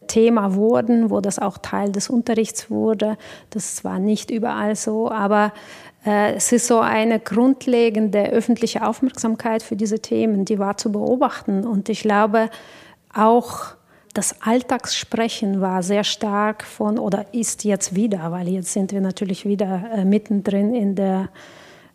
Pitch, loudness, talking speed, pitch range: 215 Hz, -20 LUFS, 150 wpm, 200-225 Hz